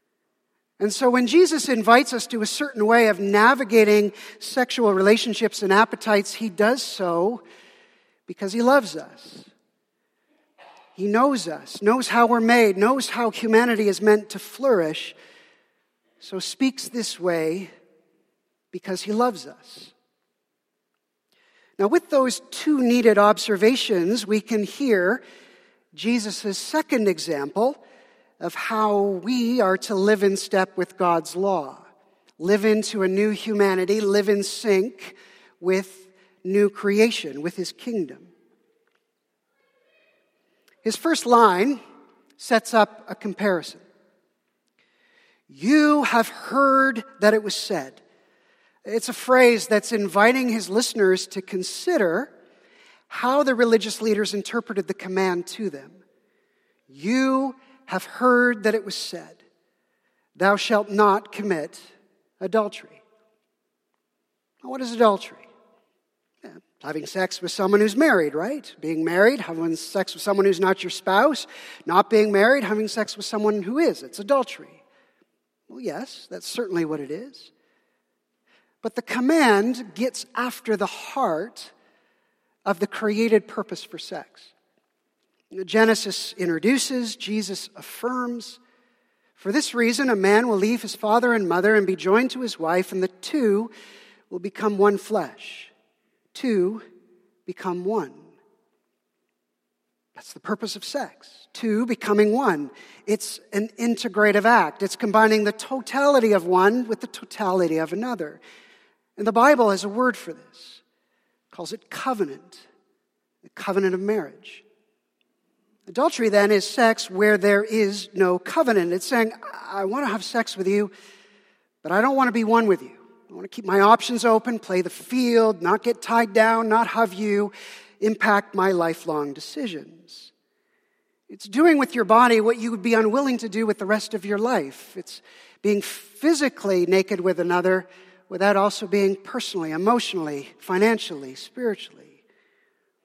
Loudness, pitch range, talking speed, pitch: -21 LUFS, 195-245 Hz, 140 wpm, 215 Hz